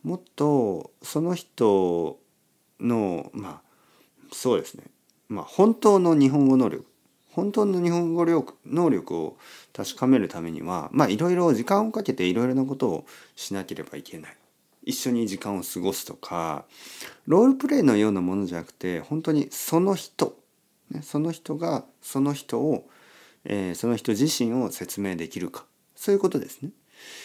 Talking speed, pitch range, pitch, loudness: 295 characters per minute, 105-175 Hz, 140 Hz, -25 LUFS